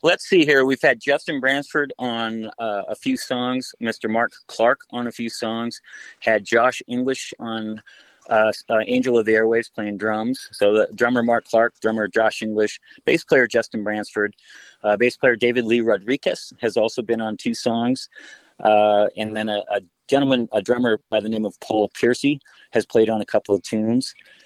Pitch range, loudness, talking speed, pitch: 110-125 Hz, -21 LUFS, 185 wpm, 115 Hz